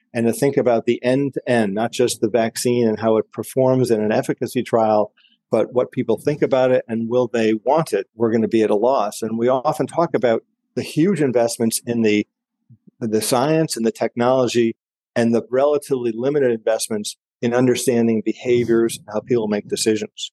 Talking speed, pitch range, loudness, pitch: 195 wpm, 115-130 Hz, -19 LUFS, 120 Hz